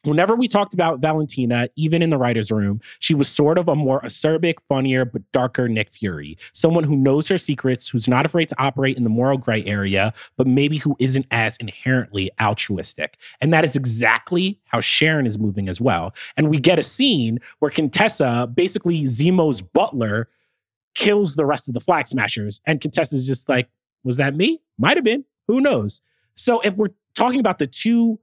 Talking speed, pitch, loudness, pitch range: 195 wpm, 140 Hz, -19 LUFS, 120-170 Hz